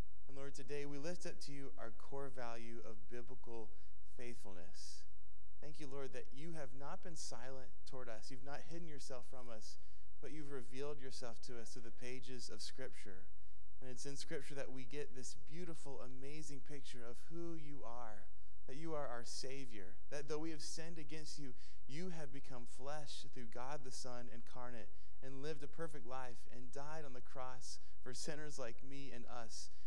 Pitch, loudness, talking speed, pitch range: 130 Hz, -52 LUFS, 190 wpm, 115-145 Hz